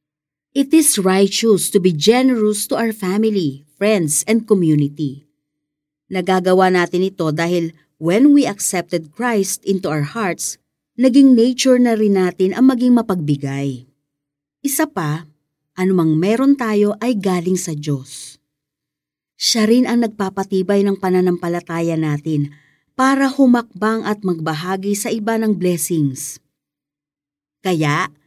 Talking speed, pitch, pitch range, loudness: 120 wpm, 185 Hz, 150-215 Hz, -16 LUFS